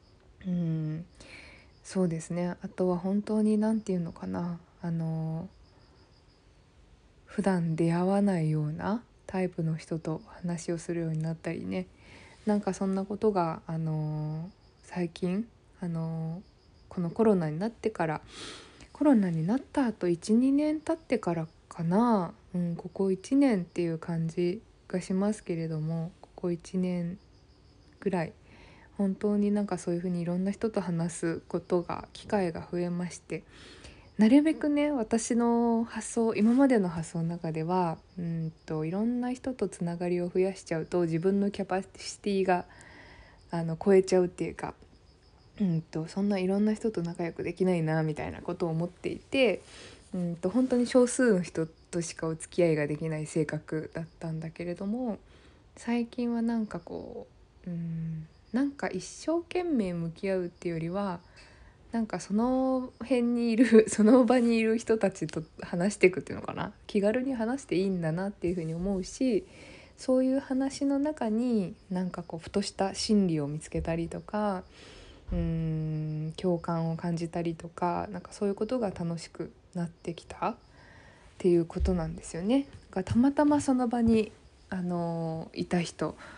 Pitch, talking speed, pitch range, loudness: 180 Hz, 305 characters per minute, 165-215 Hz, -30 LUFS